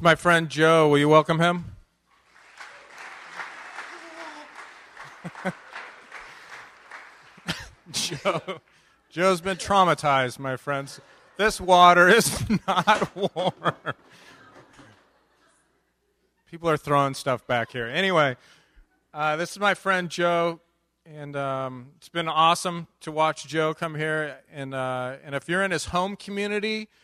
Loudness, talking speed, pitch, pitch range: -23 LUFS, 110 wpm, 165 Hz, 140-180 Hz